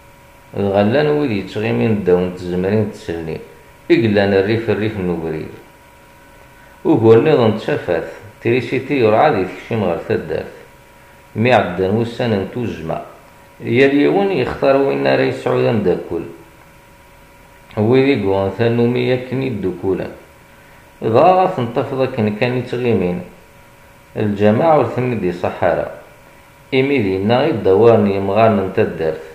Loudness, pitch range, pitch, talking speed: -16 LUFS, 95-125 Hz, 110 Hz, 105 wpm